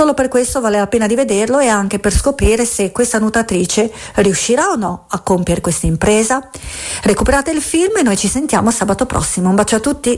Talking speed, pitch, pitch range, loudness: 205 wpm, 220 Hz, 200-260 Hz, -14 LUFS